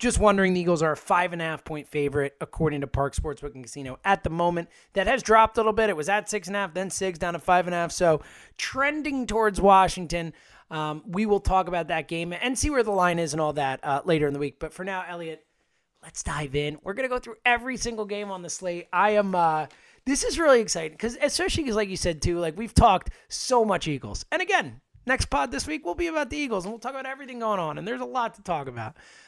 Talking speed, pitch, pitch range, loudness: 265 wpm, 180 Hz, 155-220 Hz, -25 LUFS